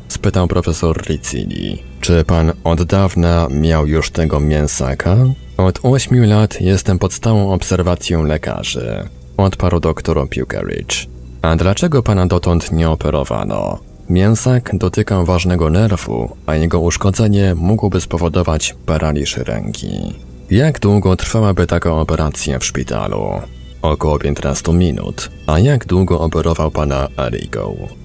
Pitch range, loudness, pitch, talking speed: 75-95 Hz, -15 LUFS, 85 Hz, 120 wpm